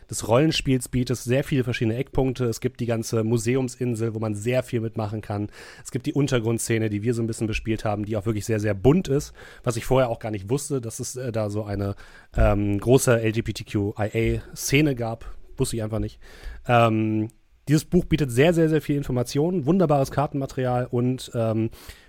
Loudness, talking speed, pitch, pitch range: -24 LUFS, 185 wpm, 120 Hz, 110-130 Hz